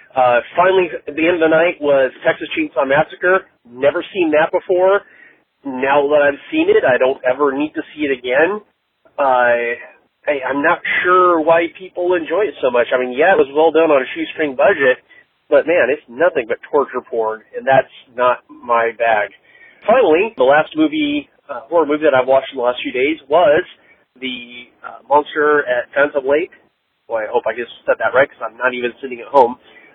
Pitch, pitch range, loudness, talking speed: 150 Hz, 130-185 Hz, -16 LUFS, 200 wpm